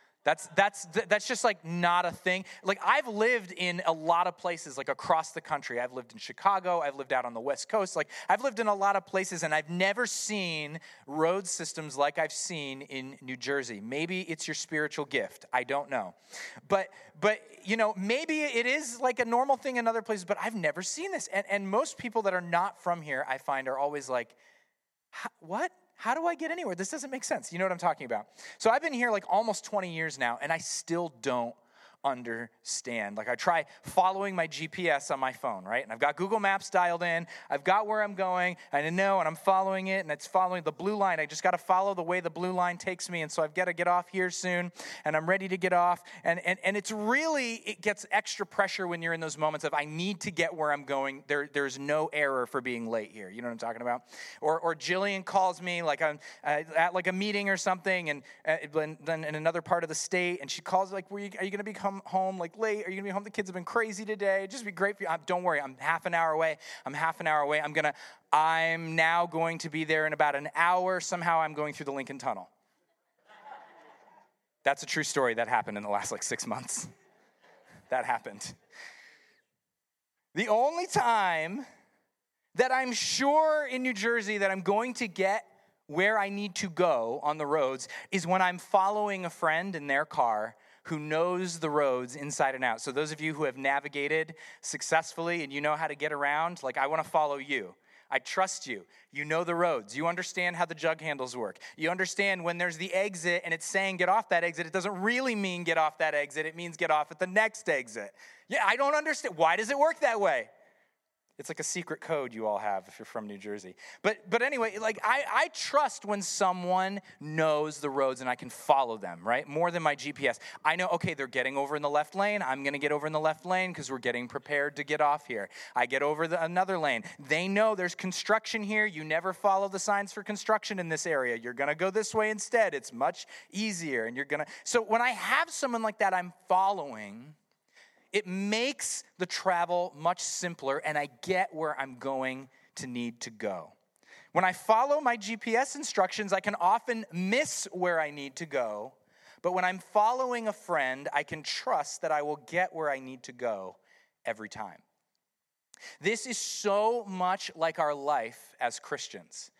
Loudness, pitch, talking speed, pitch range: -30 LUFS, 175 Hz, 225 wpm, 150-200 Hz